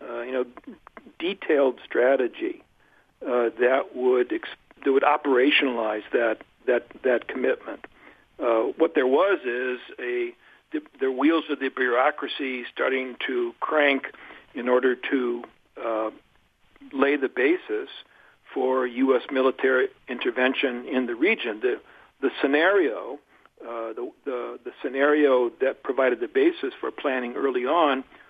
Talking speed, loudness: 130 wpm, -24 LUFS